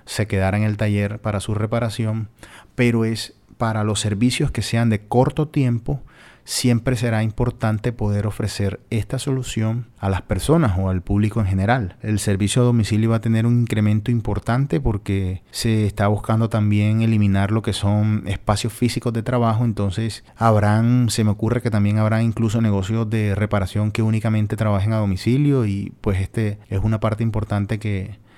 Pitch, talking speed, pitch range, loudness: 110 Hz, 170 wpm, 105-115 Hz, -20 LUFS